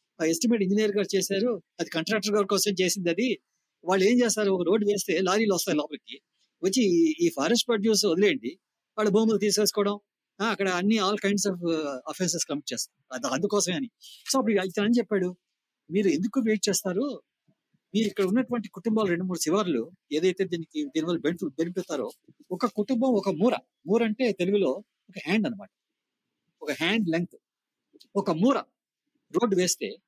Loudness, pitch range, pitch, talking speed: -26 LUFS, 180-220 Hz, 205 Hz, 150 wpm